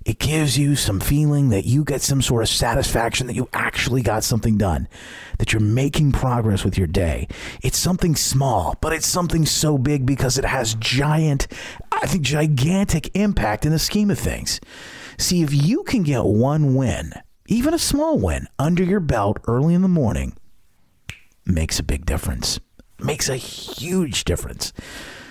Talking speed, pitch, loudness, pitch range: 175 wpm, 130 Hz, -20 LUFS, 110-155 Hz